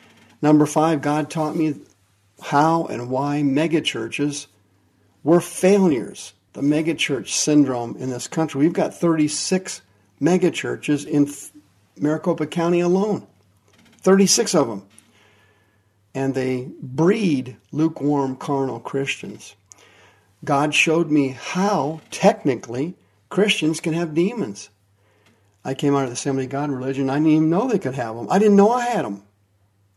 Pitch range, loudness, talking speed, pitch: 110-165 Hz, -20 LUFS, 130 wpm, 145 Hz